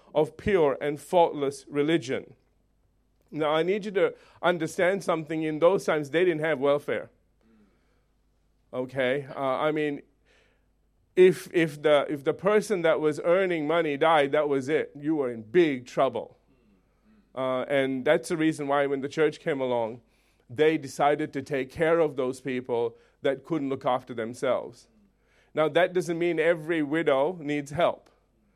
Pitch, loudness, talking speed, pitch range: 150 Hz, -26 LUFS, 155 wpm, 135-170 Hz